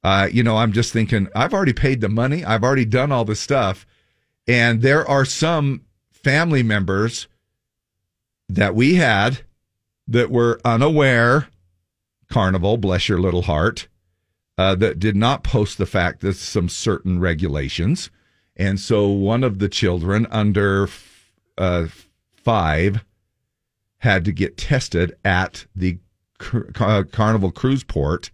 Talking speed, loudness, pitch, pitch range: 140 wpm, -19 LUFS, 105 Hz, 95-120 Hz